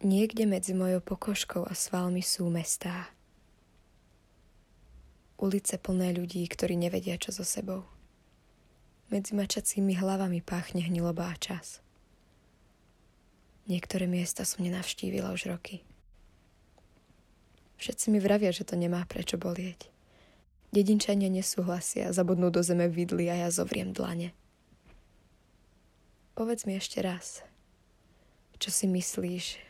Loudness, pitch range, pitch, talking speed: -31 LUFS, 170-190 Hz, 180 Hz, 110 wpm